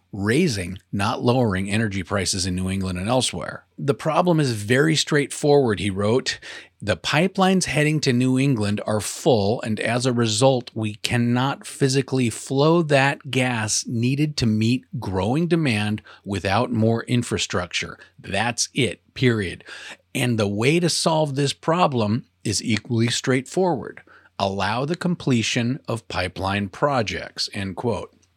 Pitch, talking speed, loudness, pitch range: 120 Hz, 135 wpm, -22 LUFS, 105-140 Hz